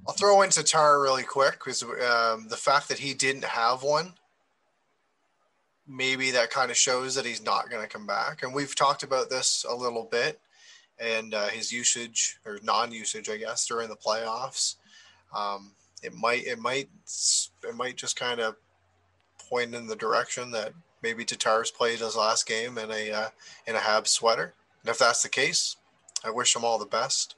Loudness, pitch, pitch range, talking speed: -26 LUFS, 115 Hz, 110-130 Hz, 185 wpm